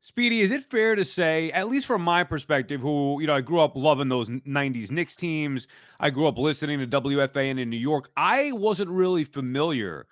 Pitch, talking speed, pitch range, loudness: 155 Hz, 210 wpm, 140-180 Hz, -25 LUFS